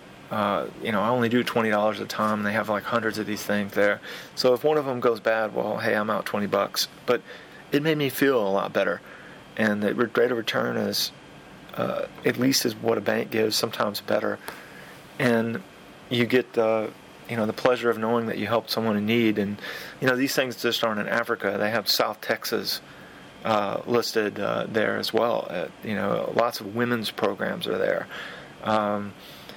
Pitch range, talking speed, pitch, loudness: 105-120 Hz, 205 wpm, 115 Hz, -25 LUFS